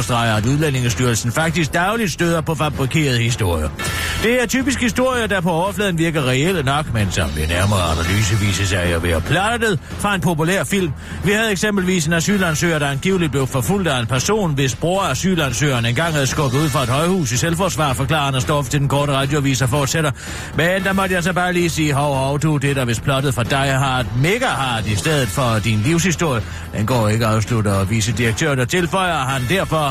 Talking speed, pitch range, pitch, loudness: 205 wpm, 120-170 Hz, 145 Hz, -18 LUFS